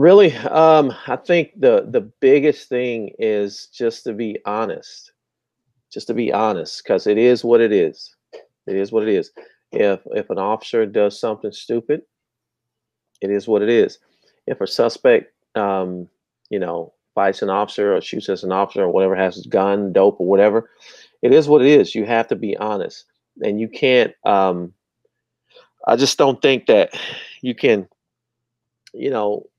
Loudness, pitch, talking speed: -18 LUFS, 150 Hz, 170 wpm